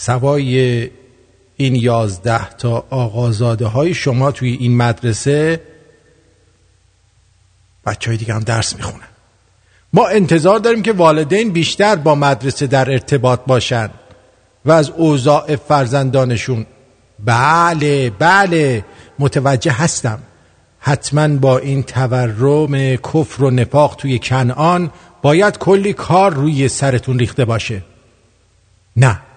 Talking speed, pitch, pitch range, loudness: 105 wpm, 130 Hz, 115-145 Hz, -14 LUFS